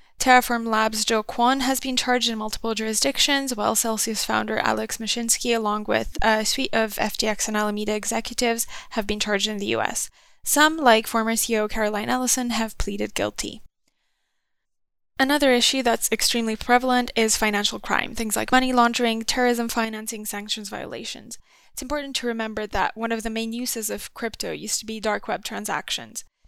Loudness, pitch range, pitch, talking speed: -23 LUFS, 215-245 Hz, 225 Hz, 165 wpm